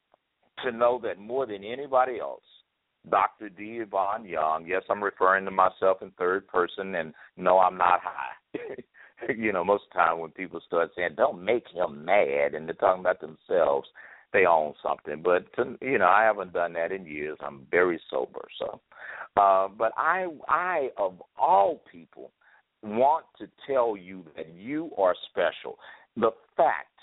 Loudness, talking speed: -26 LUFS, 170 wpm